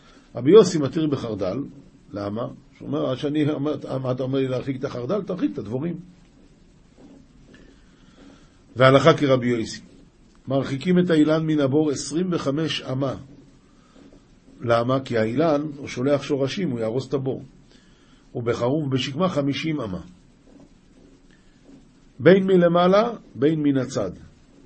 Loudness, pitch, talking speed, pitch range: -22 LUFS, 140 Hz, 115 wpm, 130-155 Hz